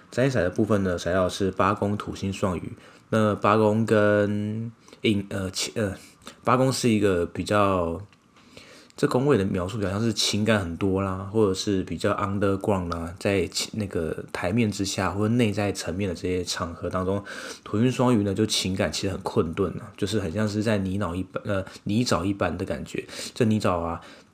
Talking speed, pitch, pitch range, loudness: 285 characters per minute, 100 Hz, 95-110 Hz, -25 LUFS